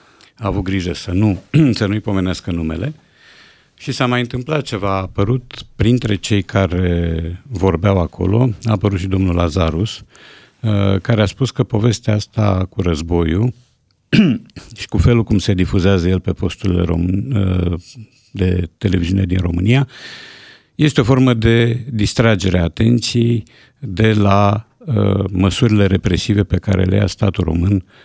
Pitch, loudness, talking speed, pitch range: 100 Hz, -16 LUFS, 135 wpm, 95-115 Hz